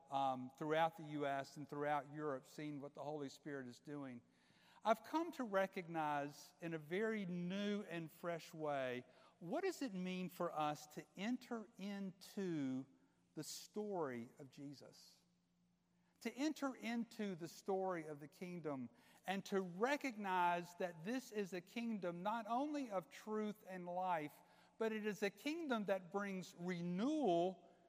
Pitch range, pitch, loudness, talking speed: 150-210 Hz, 180 Hz, -45 LUFS, 145 wpm